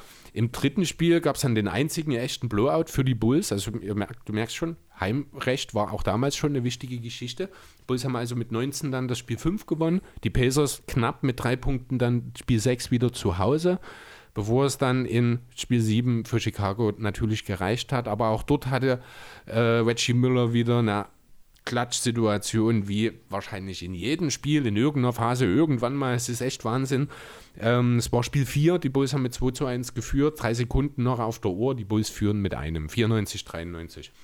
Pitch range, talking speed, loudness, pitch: 110-135 Hz, 195 wpm, -26 LUFS, 120 Hz